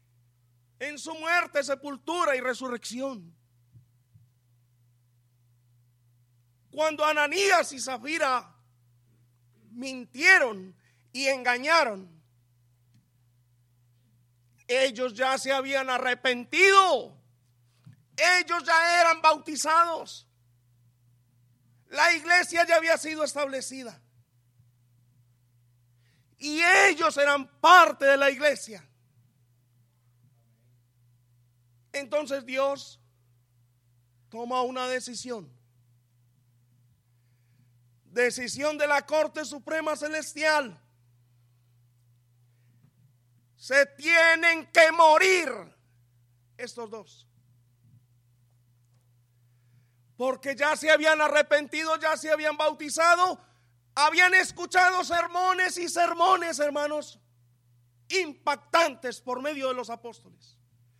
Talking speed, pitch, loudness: 70 wpm, 195 Hz, -24 LUFS